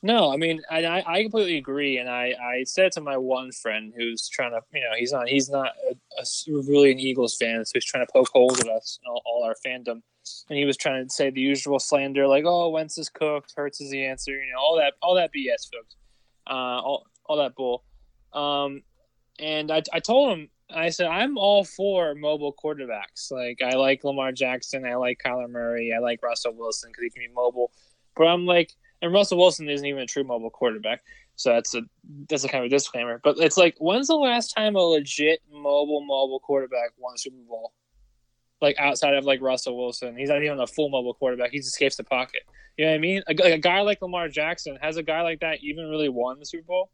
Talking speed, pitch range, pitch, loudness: 235 wpm, 125-160 Hz, 140 Hz, -24 LUFS